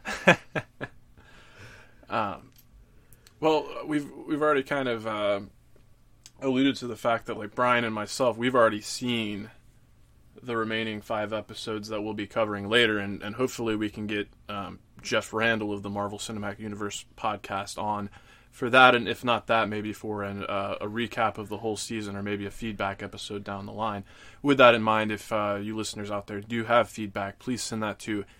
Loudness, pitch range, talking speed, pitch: -27 LUFS, 105-120 Hz, 180 wpm, 110 Hz